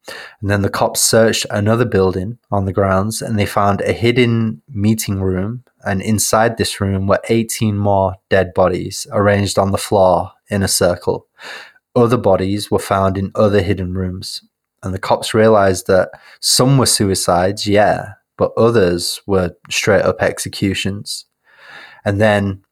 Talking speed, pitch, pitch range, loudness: 155 wpm, 100 Hz, 95-110 Hz, -15 LUFS